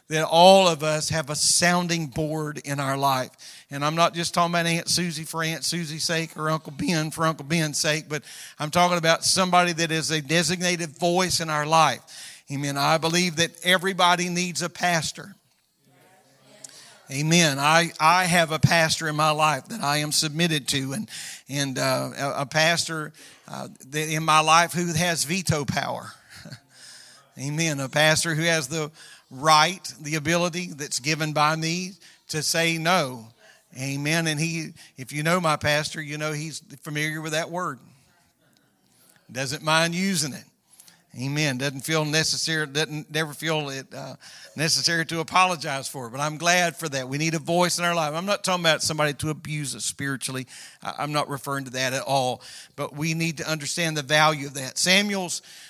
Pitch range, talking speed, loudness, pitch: 150-170 Hz, 180 wpm, -23 LUFS, 155 Hz